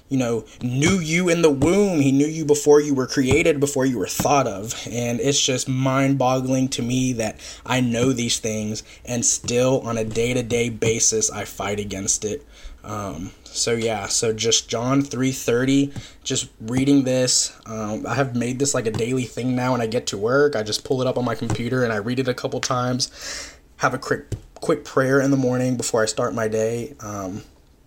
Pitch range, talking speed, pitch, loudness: 115-135 Hz, 200 wpm, 125 Hz, -21 LUFS